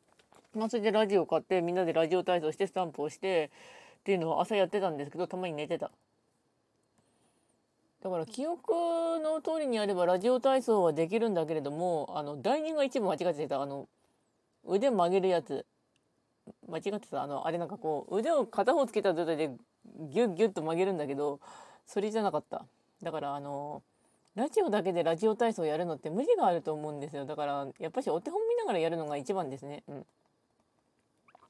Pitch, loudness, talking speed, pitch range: 180 Hz, -32 LUFS, 385 characters per minute, 155-225 Hz